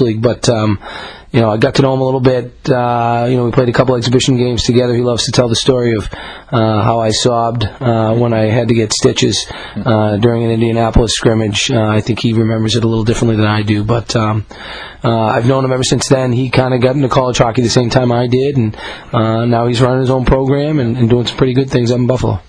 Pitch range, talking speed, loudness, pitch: 115-130 Hz, 260 wpm, -13 LUFS, 120 Hz